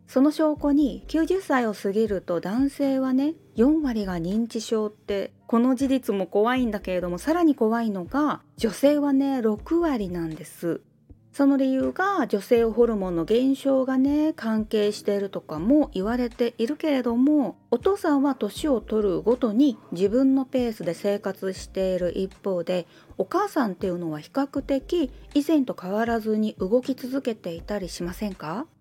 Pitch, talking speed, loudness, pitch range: 230 Hz, 310 characters per minute, -24 LUFS, 200-275 Hz